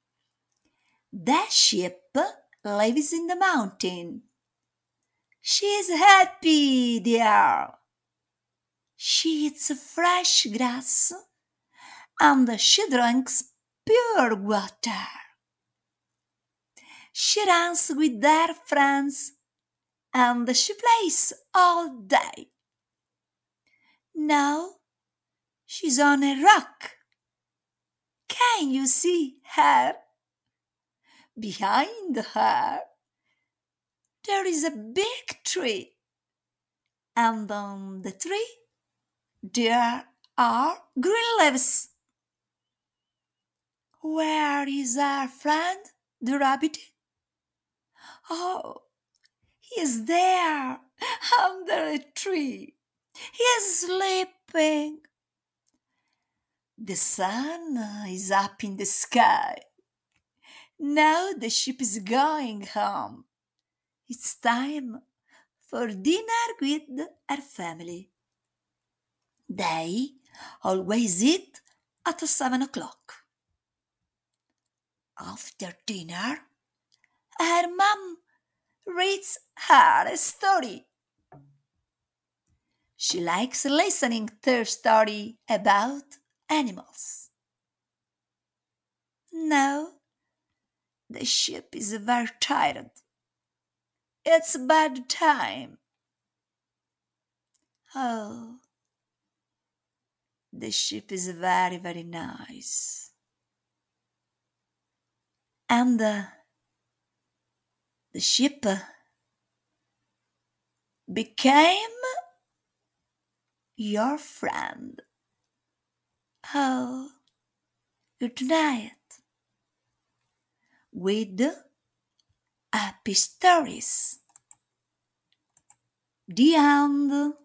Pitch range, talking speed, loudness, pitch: 230-340 Hz, 65 wpm, -23 LUFS, 285 Hz